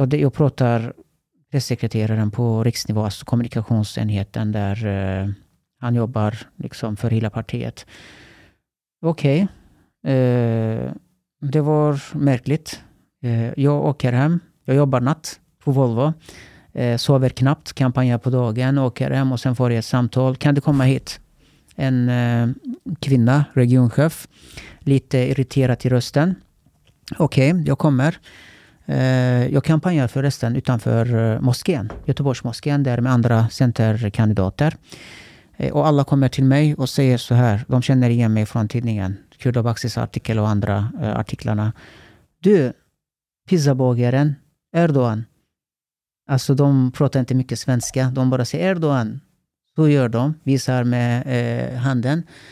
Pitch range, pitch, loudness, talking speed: 115-140 Hz, 130 Hz, -19 LUFS, 120 wpm